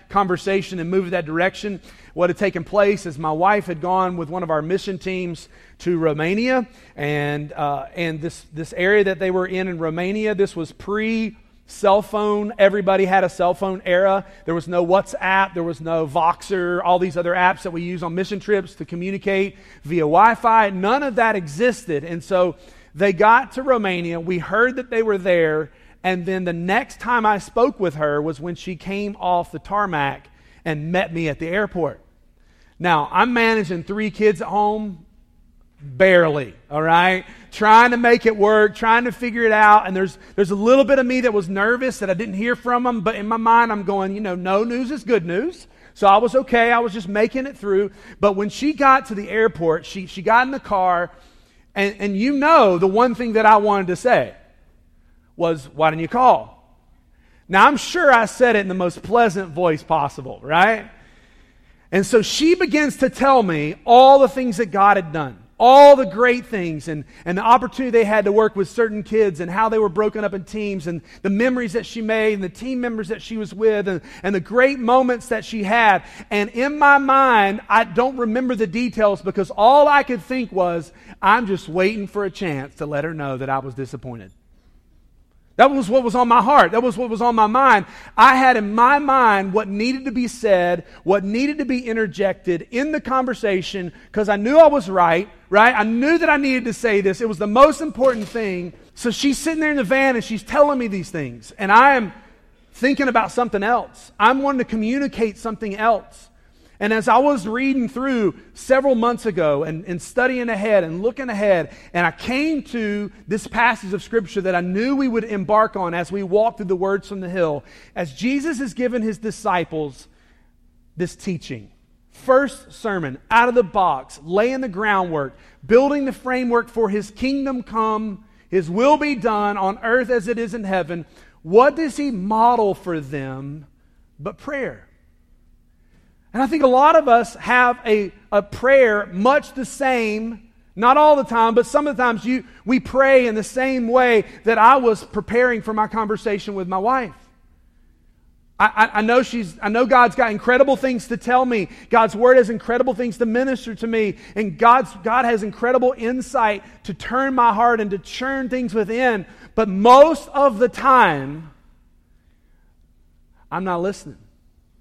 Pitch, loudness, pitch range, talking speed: 210 Hz, -18 LUFS, 180-240 Hz, 200 wpm